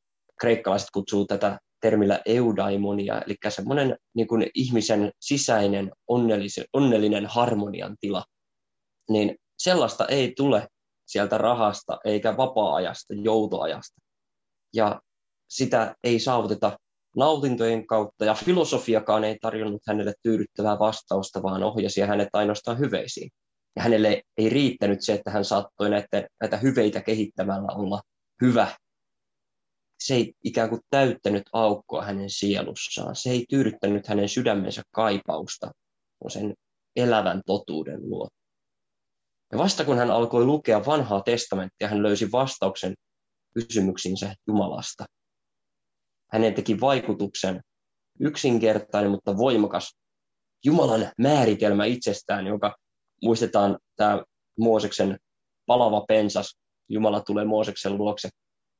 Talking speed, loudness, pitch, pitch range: 105 wpm, -25 LUFS, 105 Hz, 100-115 Hz